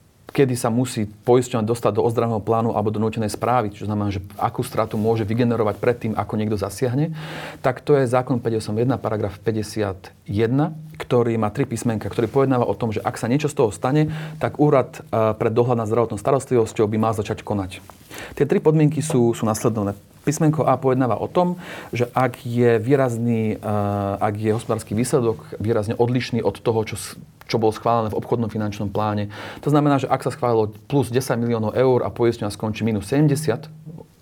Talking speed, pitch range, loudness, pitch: 180 wpm, 110-130 Hz, -21 LUFS, 115 Hz